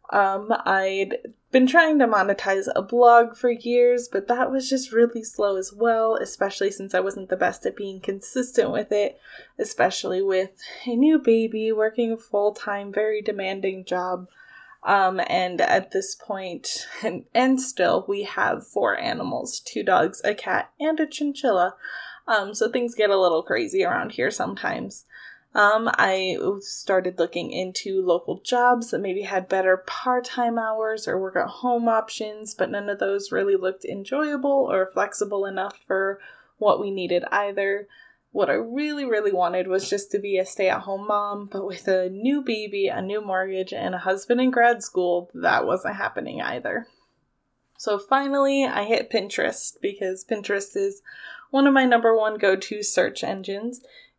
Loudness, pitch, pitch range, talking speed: -23 LUFS, 205 Hz, 195-240 Hz, 170 wpm